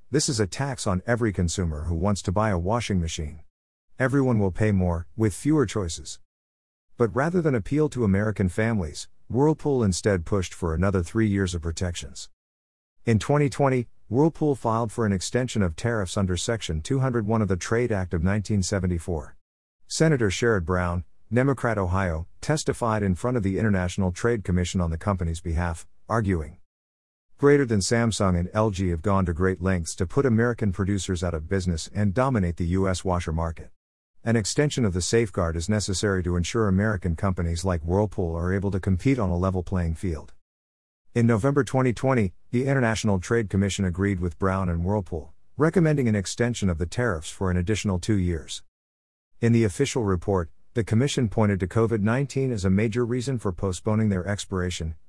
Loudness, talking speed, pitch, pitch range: -25 LUFS, 175 wpm, 100 Hz, 90-115 Hz